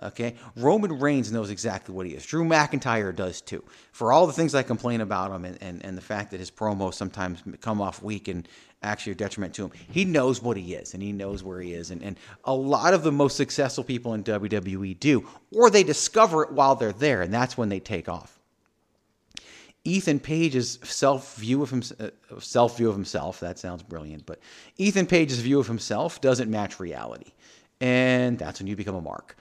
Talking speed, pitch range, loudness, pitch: 210 wpm, 95-135 Hz, -25 LUFS, 110 Hz